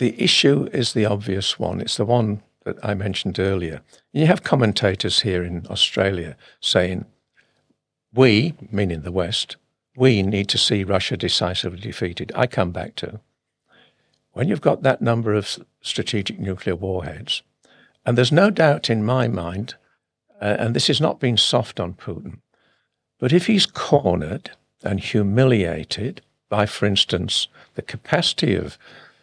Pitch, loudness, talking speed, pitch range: 105 Hz, -20 LUFS, 150 wpm, 95-120 Hz